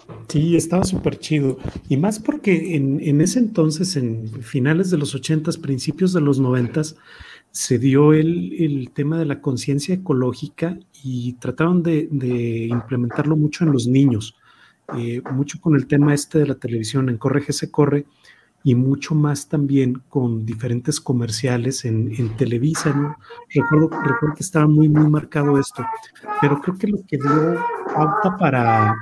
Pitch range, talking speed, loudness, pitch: 130-160 Hz, 160 wpm, -19 LUFS, 145 Hz